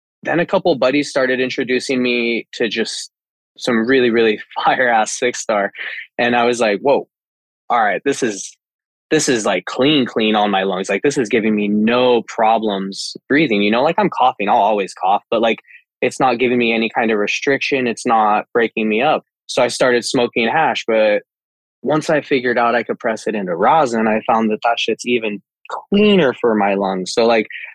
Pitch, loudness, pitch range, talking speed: 115 Hz, -16 LUFS, 110-125 Hz, 200 wpm